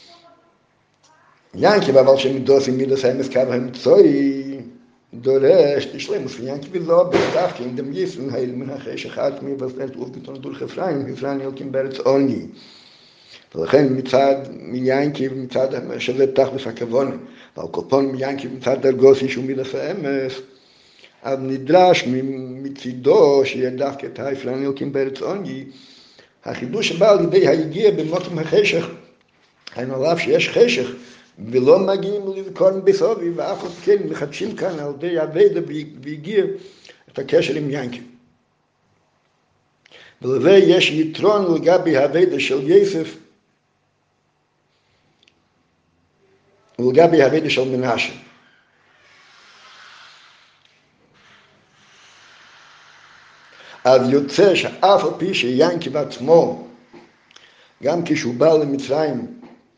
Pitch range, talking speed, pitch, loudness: 130-180 Hz, 95 wpm, 135 Hz, -18 LUFS